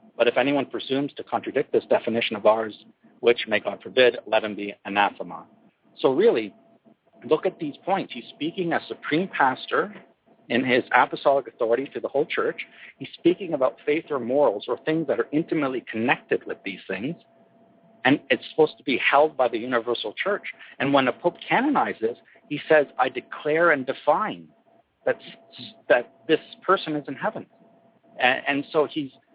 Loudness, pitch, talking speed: -24 LUFS, 150 Hz, 170 wpm